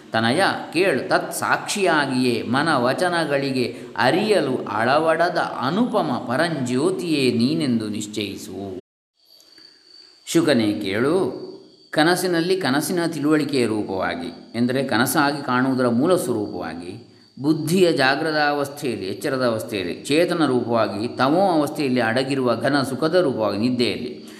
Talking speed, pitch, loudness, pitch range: 90 wpm, 145 Hz, -21 LUFS, 125-175 Hz